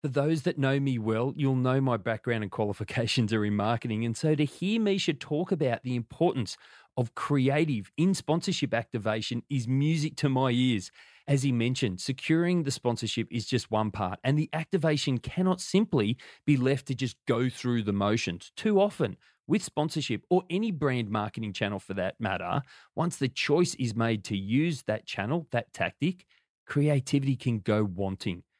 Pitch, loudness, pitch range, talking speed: 130 Hz, -29 LUFS, 115-155 Hz, 175 wpm